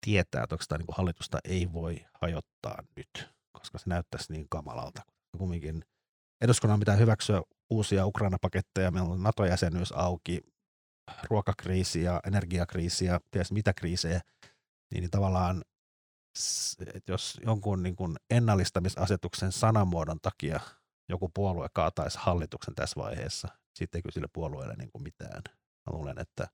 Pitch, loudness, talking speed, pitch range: 90 Hz, -31 LUFS, 135 wpm, 85-100 Hz